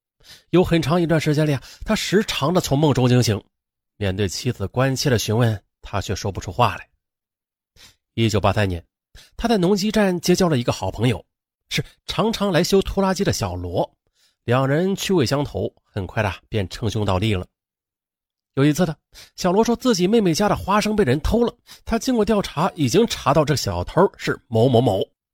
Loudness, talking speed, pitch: -20 LUFS, 270 characters per minute, 125 Hz